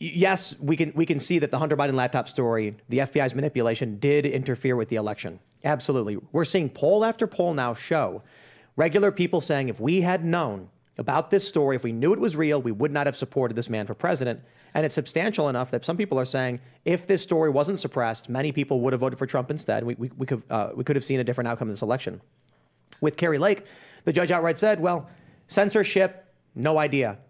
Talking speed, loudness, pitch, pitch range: 220 wpm, -25 LUFS, 145 Hz, 125-170 Hz